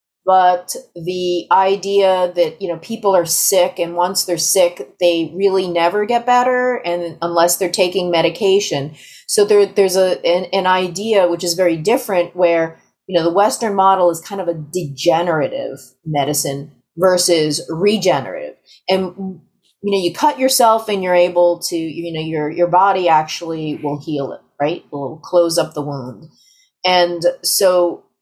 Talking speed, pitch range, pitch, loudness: 160 wpm, 165-190 Hz, 175 Hz, -16 LUFS